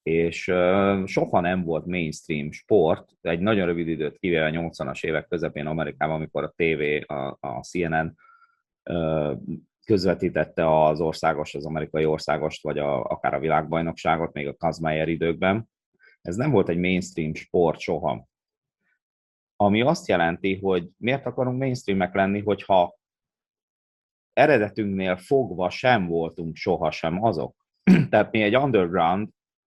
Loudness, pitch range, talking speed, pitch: -24 LUFS, 80-100 Hz, 135 wpm, 85 Hz